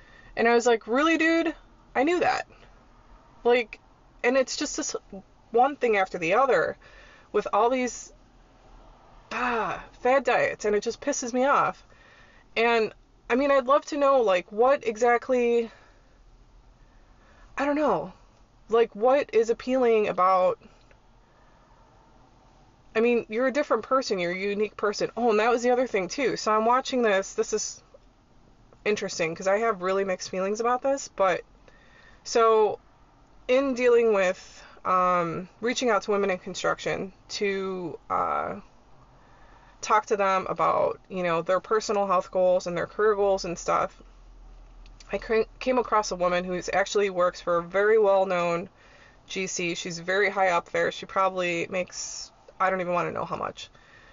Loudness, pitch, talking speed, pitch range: -25 LUFS, 210 Hz, 155 wpm, 185-245 Hz